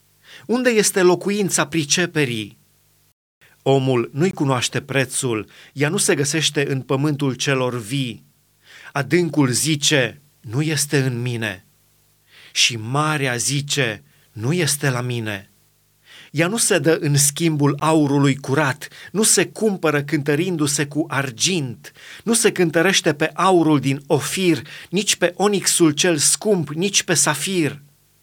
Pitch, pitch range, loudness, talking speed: 150 Hz, 135-170 Hz, -19 LUFS, 125 wpm